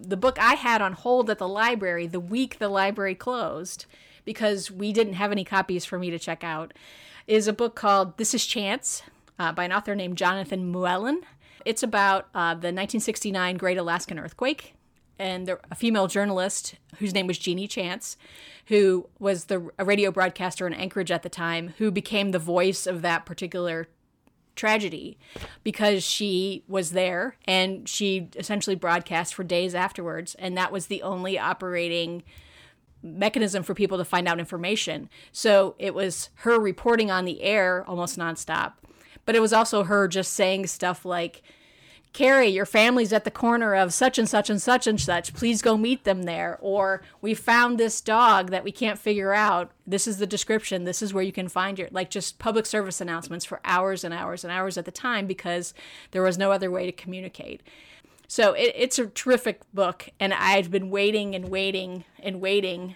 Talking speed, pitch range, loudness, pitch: 185 wpm, 180-210 Hz, -25 LUFS, 195 Hz